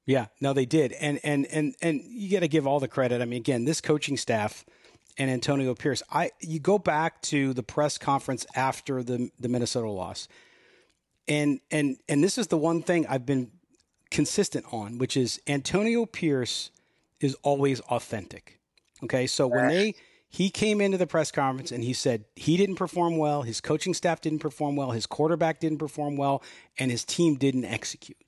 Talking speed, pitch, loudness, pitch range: 185 wpm, 145 Hz, -27 LUFS, 130-160 Hz